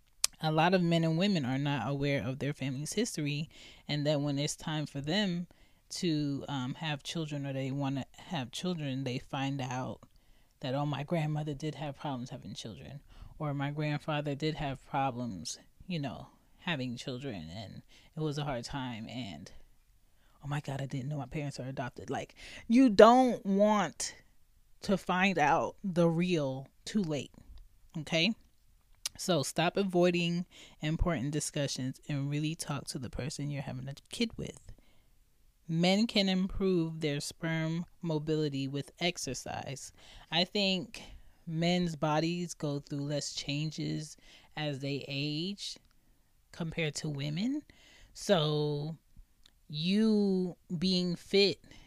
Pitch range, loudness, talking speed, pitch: 140-175 Hz, -33 LUFS, 140 wpm, 150 Hz